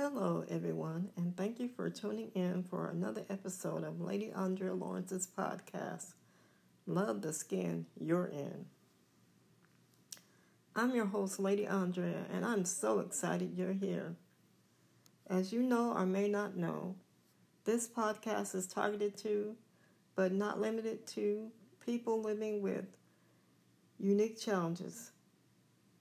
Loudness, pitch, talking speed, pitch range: -38 LUFS, 195 Hz, 120 wpm, 185-215 Hz